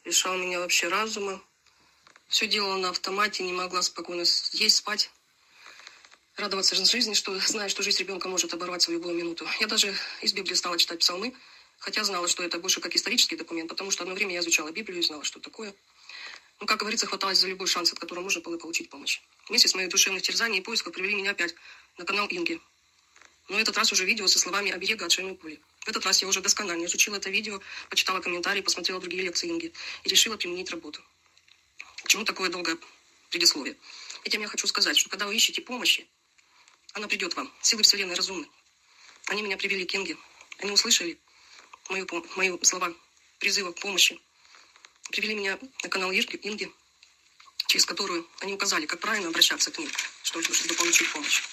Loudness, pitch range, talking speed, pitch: -25 LUFS, 180-215 Hz, 185 wpm, 195 Hz